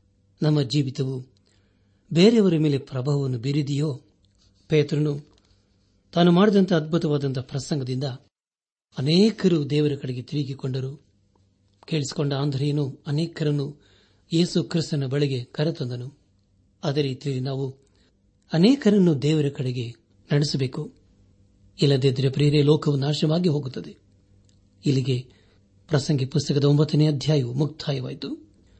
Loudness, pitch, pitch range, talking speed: -23 LUFS, 140 Hz, 100-150 Hz, 85 wpm